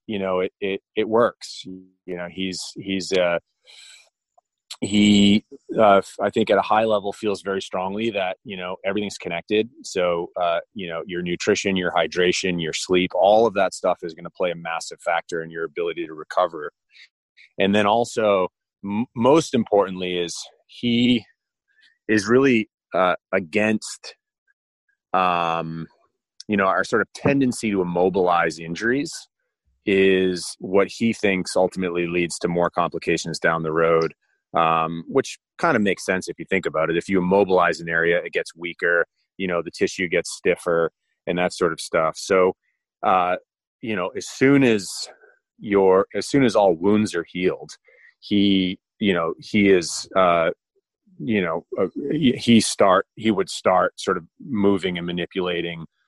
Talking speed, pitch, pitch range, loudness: 160 wpm, 100 Hz, 90-120 Hz, -21 LUFS